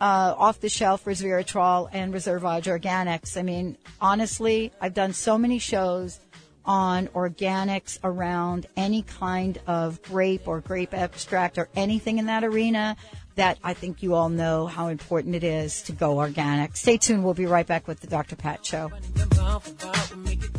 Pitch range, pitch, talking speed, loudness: 170-195 Hz, 180 Hz, 155 wpm, -25 LUFS